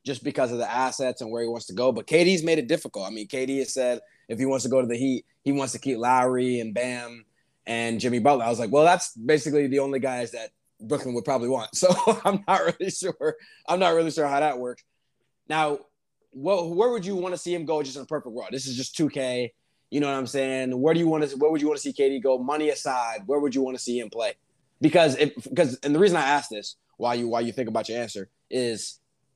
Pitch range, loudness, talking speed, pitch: 125-155 Hz, -25 LUFS, 265 wpm, 135 Hz